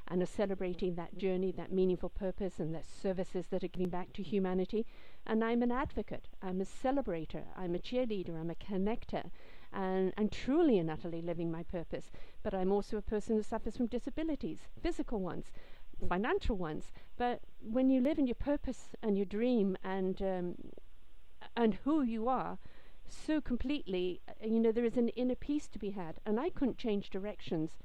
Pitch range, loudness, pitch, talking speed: 185-240 Hz, -36 LUFS, 200 Hz, 185 wpm